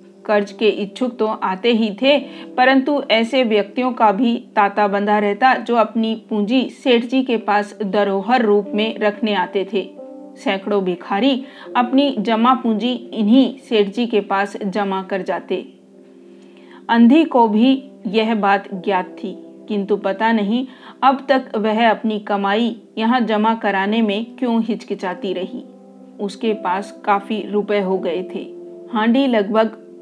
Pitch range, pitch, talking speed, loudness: 200-245 Hz, 215 Hz, 145 wpm, -18 LUFS